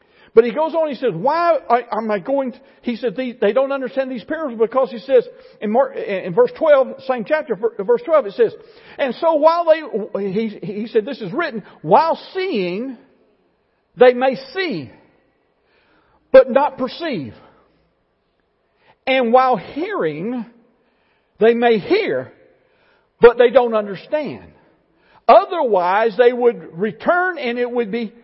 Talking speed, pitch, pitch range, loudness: 145 wpm, 265 Hz, 235-330 Hz, -17 LUFS